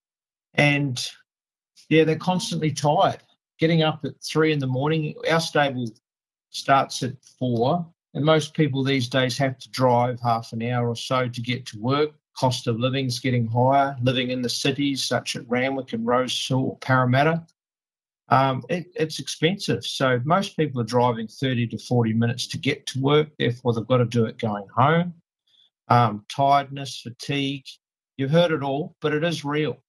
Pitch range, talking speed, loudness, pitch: 120-150 Hz, 175 wpm, -23 LUFS, 135 Hz